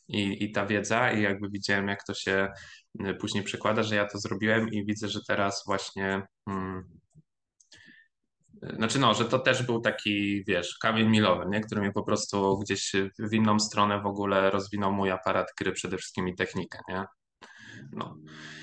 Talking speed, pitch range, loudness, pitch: 170 wpm, 95-105 Hz, -28 LUFS, 100 Hz